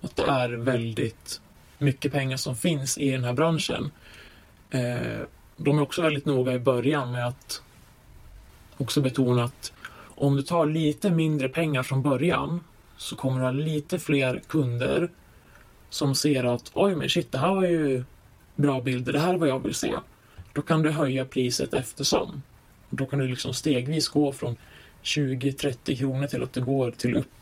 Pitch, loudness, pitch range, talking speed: 140 Hz, -26 LUFS, 125-150 Hz, 175 wpm